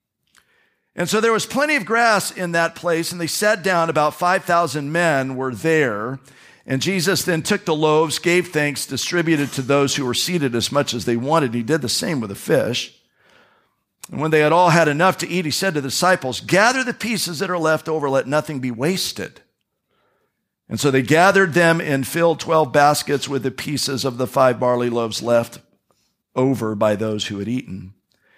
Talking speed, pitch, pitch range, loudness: 200 wpm, 155 Hz, 130-175 Hz, -19 LUFS